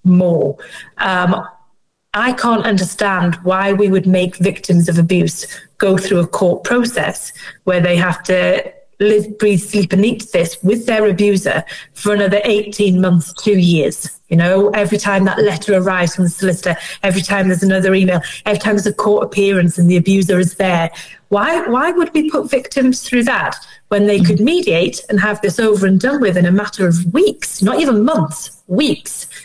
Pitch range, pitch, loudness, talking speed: 180-210 Hz, 195 Hz, -14 LUFS, 185 wpm